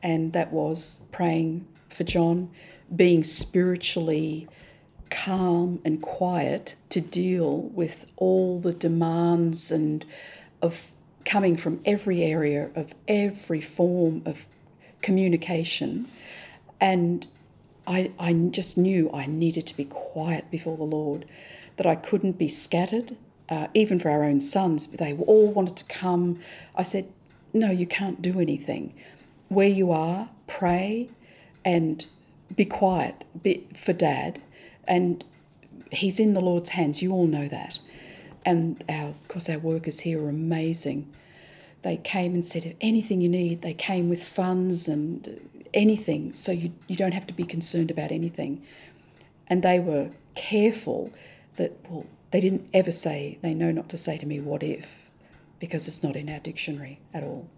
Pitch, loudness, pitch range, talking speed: 170 Hz, -26 LUFS, 160-185 Hz, 150 wpm